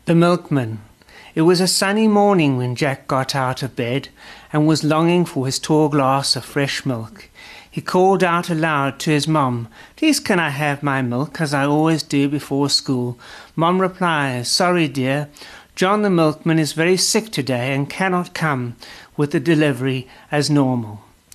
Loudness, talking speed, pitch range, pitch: -18 LUFS, 170 wpm, 135-170 Hz, 150 Hz